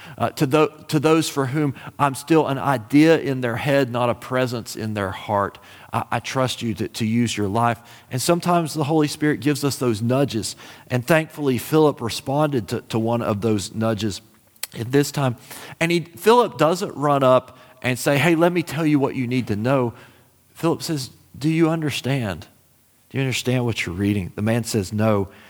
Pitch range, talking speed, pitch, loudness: 115-150 Hz, 200 wpm, 130 Hz, -21 LUFS